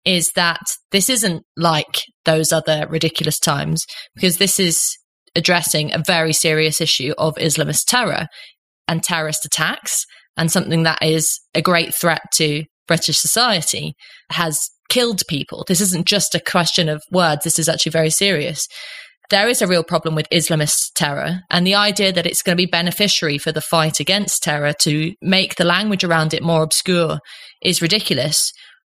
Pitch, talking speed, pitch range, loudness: 165 Hz, 165 wpm, 160-185 Hz, -16 LUFS